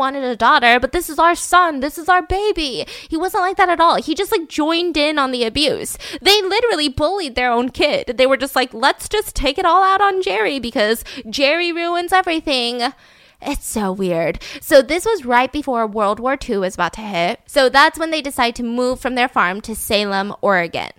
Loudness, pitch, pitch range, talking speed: -17 LUFS, 280 Hz, 240-340 Hz, 215 wpm